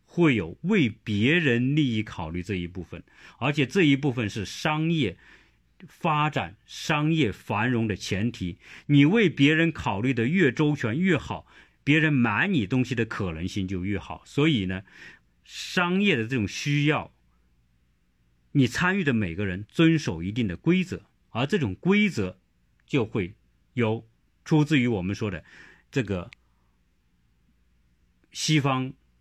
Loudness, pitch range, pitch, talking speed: -25 LUFS, 90-145 Hz, 115 Hz, 205 characters per minute